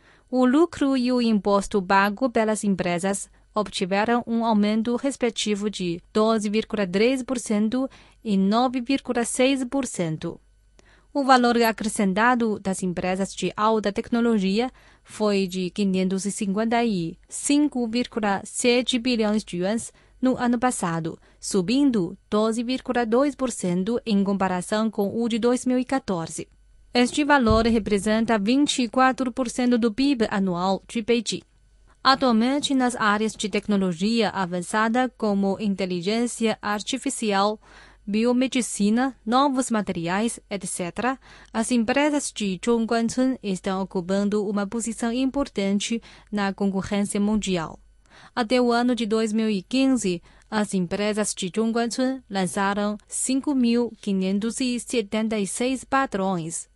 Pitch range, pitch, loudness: 200-245 Hz, 220 Hz, -23 LUFS